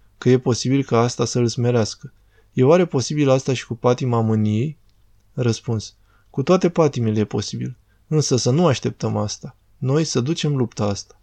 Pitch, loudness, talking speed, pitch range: 120 Hz, -20 LUFS, 170 wpm, 110-135 Hz